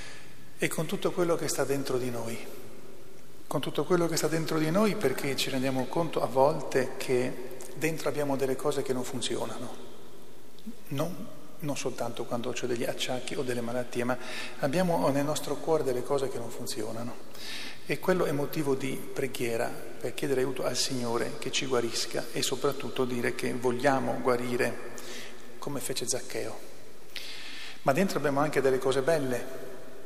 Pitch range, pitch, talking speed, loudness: 125-150 Hz, 135 Hz, 160 wpm, -30 LUFS